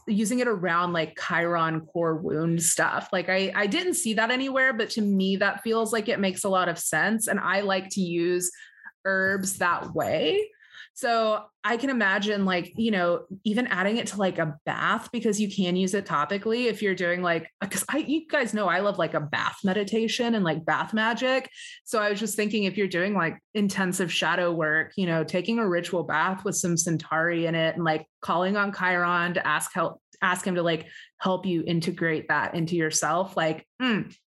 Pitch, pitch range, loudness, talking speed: 190 Hz, 170-220 Hz, -25 LUFS, 205 wpm